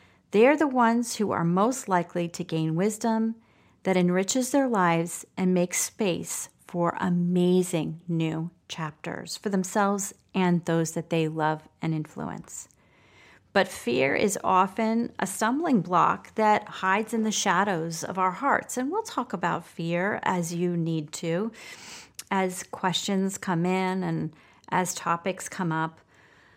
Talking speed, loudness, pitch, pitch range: 140 wpm, -26 LUFS, 185 Hz, 170-210 Hz